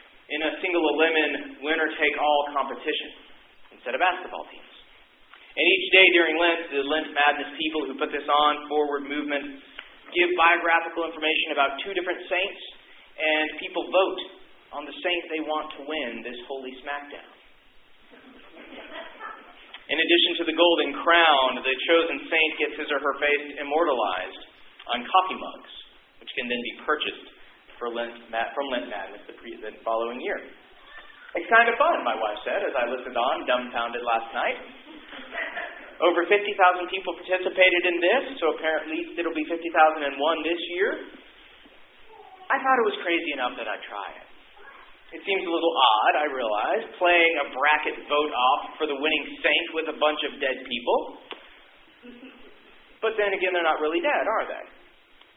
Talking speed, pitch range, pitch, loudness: 165 wpm, 145-180 Hz, 160 Hz, -24 LUFS